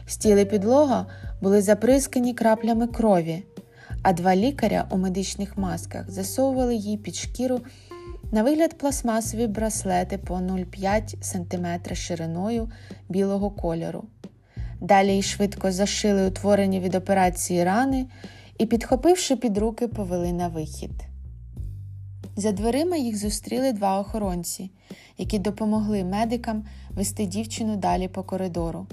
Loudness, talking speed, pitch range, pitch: -24 LUFS, 115 wpm, 175-225 Hz, 200 Hz